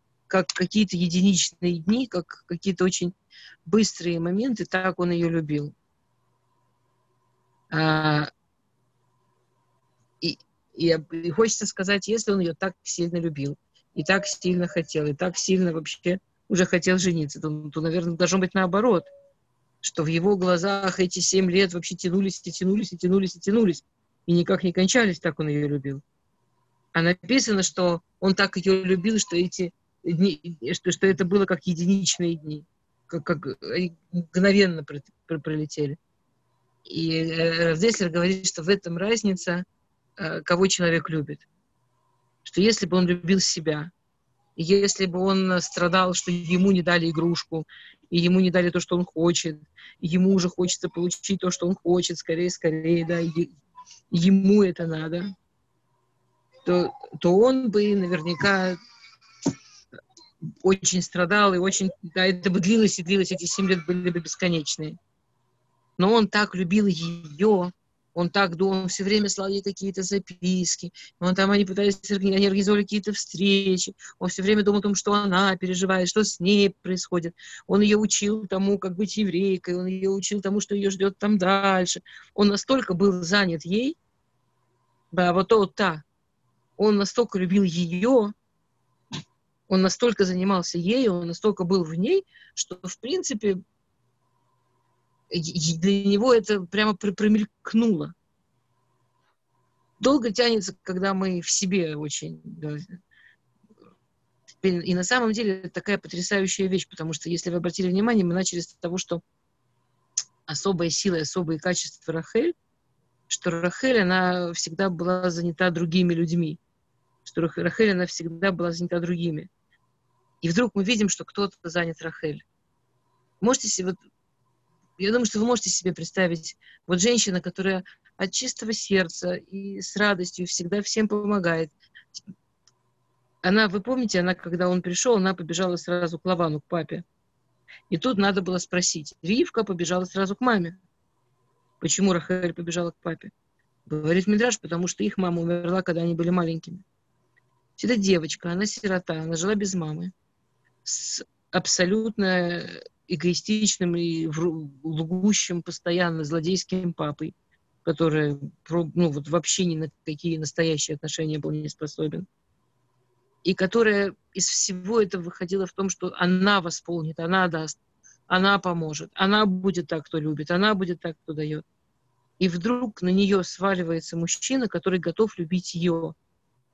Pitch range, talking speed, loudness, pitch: 170-195 Hz, 145 wpm, -24 LUFS, 180 Hz